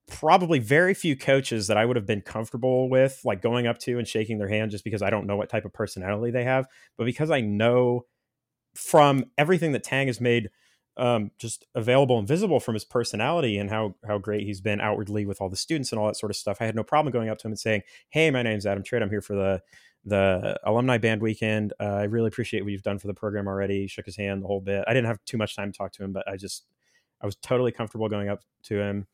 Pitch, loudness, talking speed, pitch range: 110 Hz, -26 LUFS, 260 wpm, 105-125 Hz